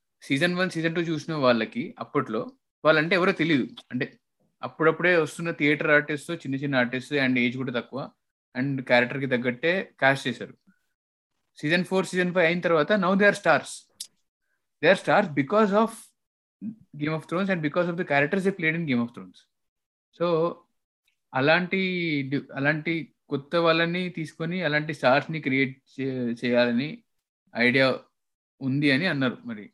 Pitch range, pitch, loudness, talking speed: 135-180 Hz, 155 Hz, -25 LUFS, 145 wpm